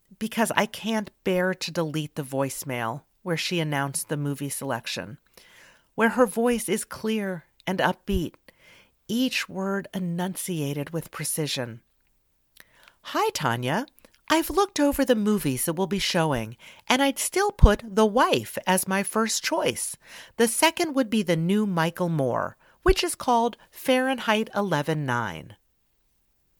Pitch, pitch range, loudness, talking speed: 190 Hz, 150-230 Hz, -25 LUFS, 135 wpm